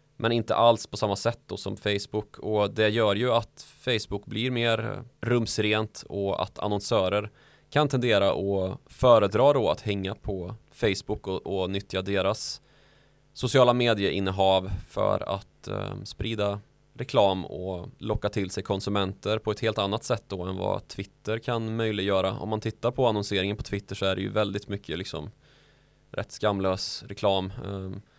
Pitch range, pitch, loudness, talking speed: 100-120 Hz, 105 Hz, -27 LUFS, 155 wpm